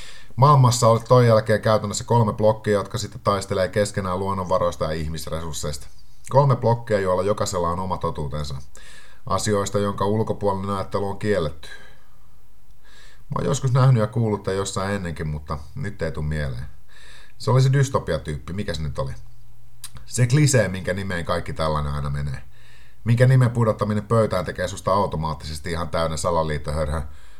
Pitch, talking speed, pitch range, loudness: 100 Hz, 145 wpm, 80-115 Hz, -22 LUFS